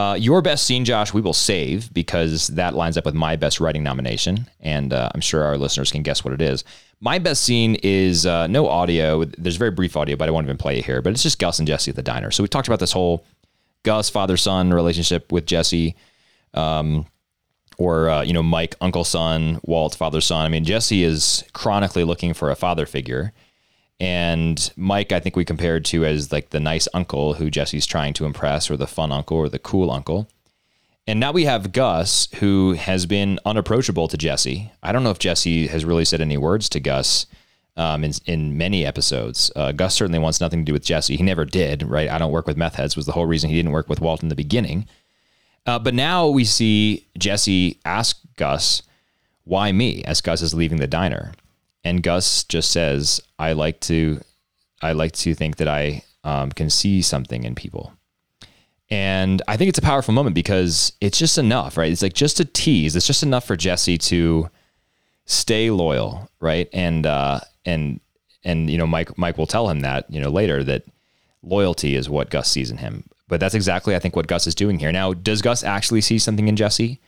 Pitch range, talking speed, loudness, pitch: 80-100 Hz, 210 wpm, -20 LUFS, 85 Hz